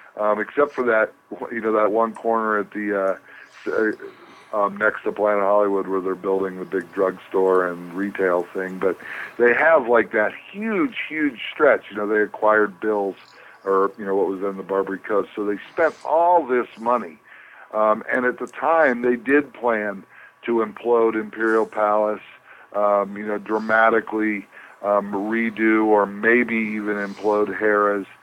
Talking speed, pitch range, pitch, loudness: 165 wpm, 100-115 Hz, 105 Hz, -21 LUFS